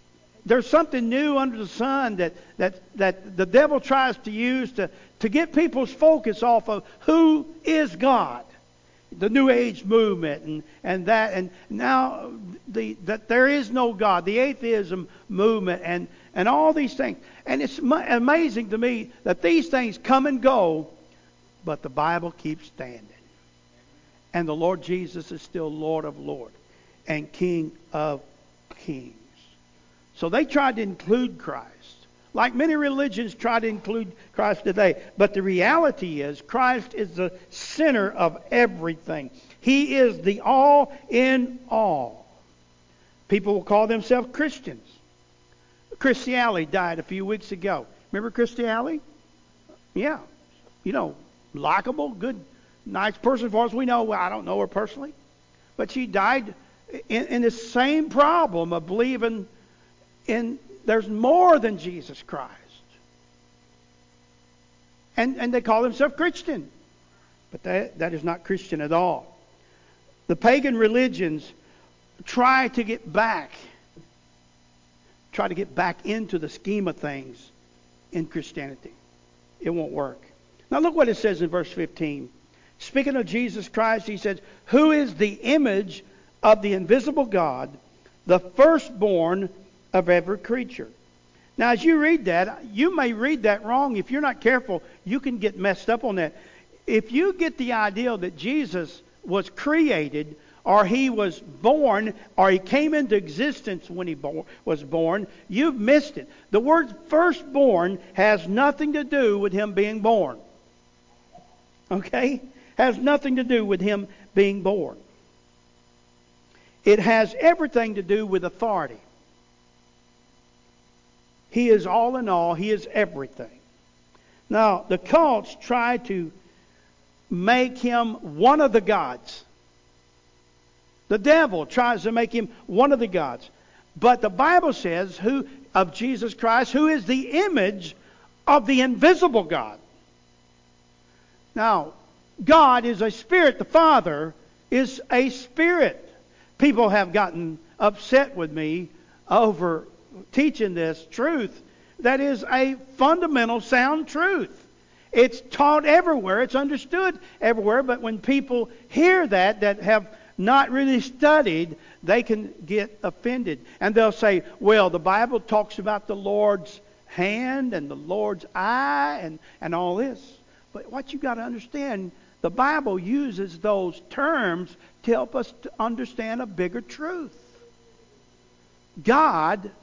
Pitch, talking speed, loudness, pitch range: 210 Hz, 140 wpm, -22 LUFS, 160-255 Hz